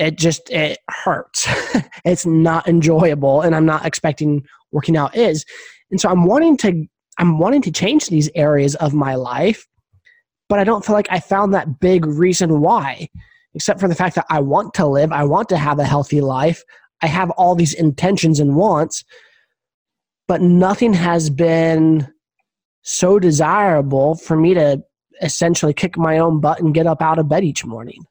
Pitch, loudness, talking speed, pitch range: 165 Hz, -16 LUFS, 180 wpm, 155-185 Hz